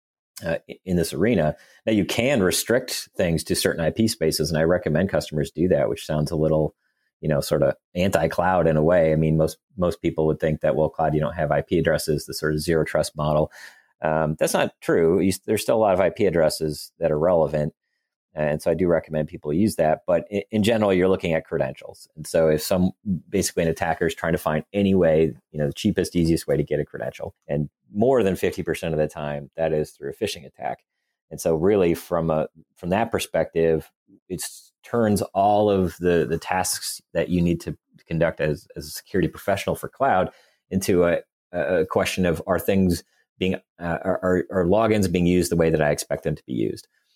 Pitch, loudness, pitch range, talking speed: 80 Hz, -23 LUFS, 75-90 Hz, 215 wpm